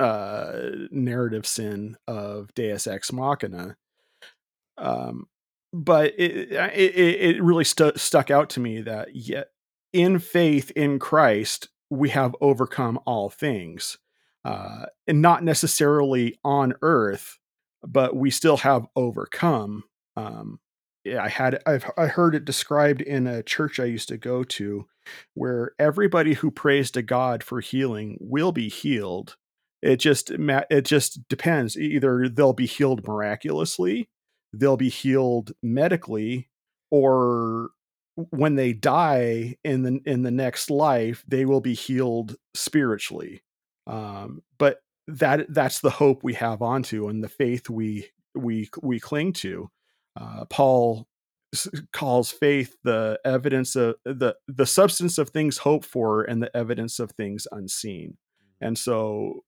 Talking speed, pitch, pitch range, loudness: 135 wpm, 130 Hz, 120-150 Hz, -23 LUFS